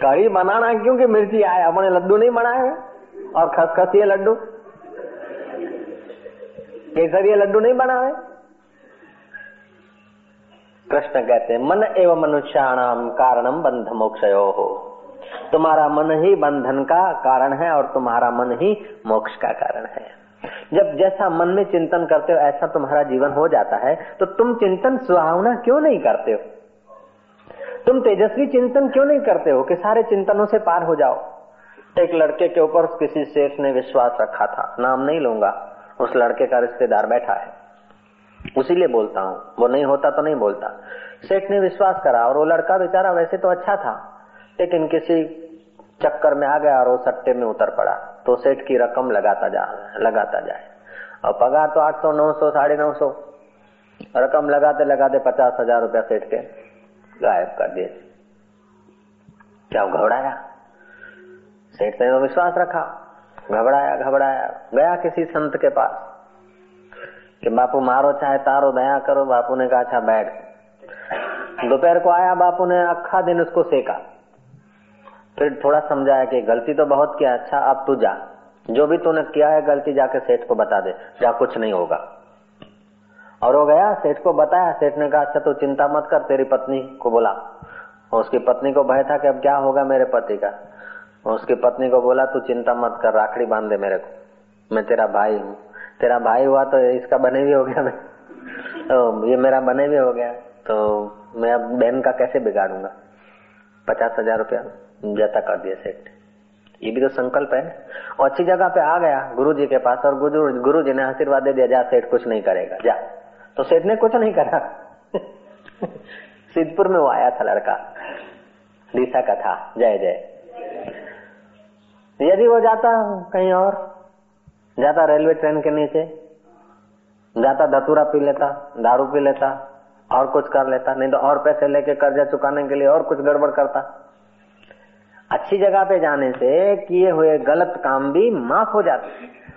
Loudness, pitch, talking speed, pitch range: -18 LUFS, 150 Hz, 170 wpm, 130-190 Hz